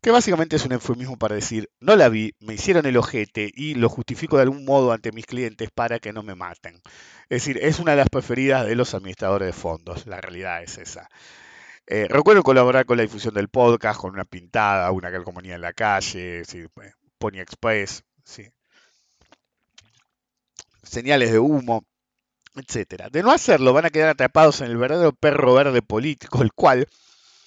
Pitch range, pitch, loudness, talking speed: 105-135 Hz, 115 Hz, -20 LUFS, 180 wpm